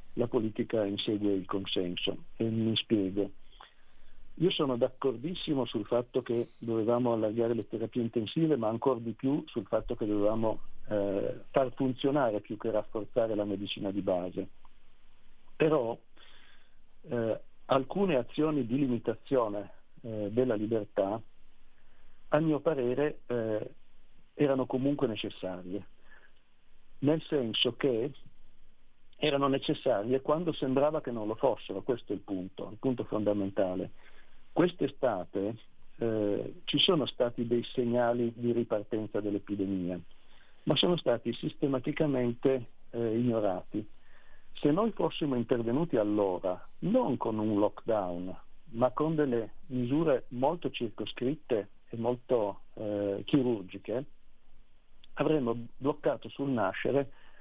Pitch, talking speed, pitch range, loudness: 115 Hz, 115 wpm, 105-135 Hz, -32 LUFS